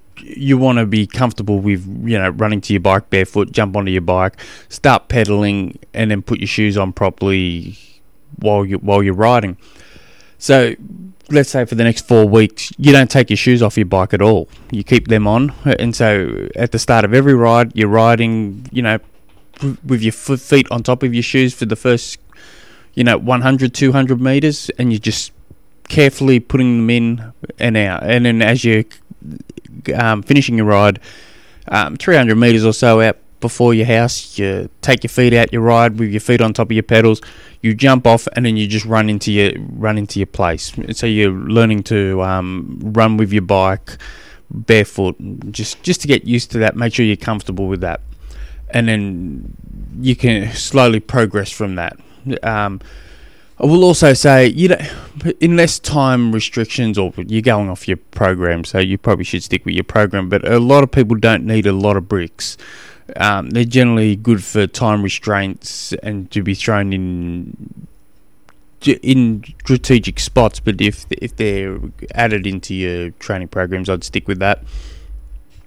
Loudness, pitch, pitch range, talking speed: -14 LUFS, 110 Hz, 100-120 Hz, 185 wpm